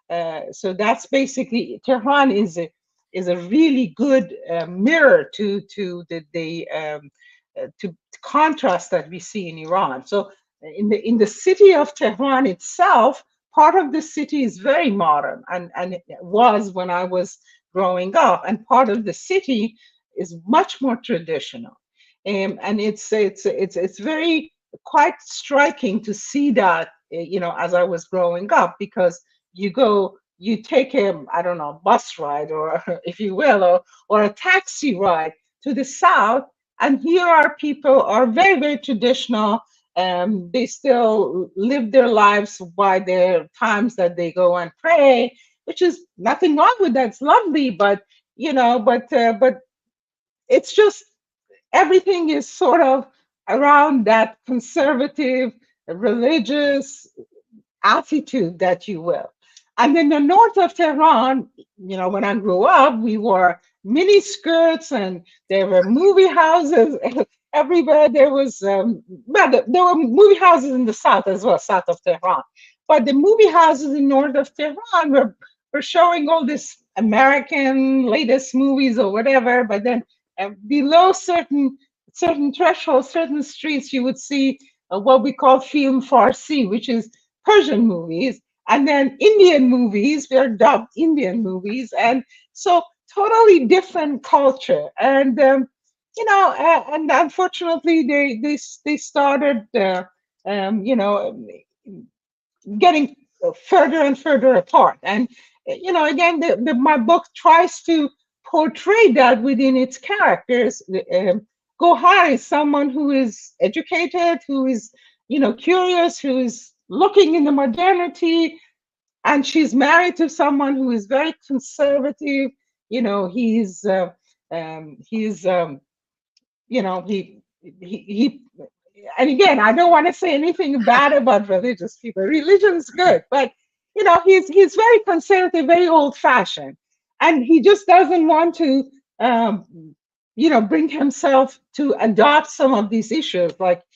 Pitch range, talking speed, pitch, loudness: 210-325 Hz, 150 wpm, 270 Hz, -17 LUFS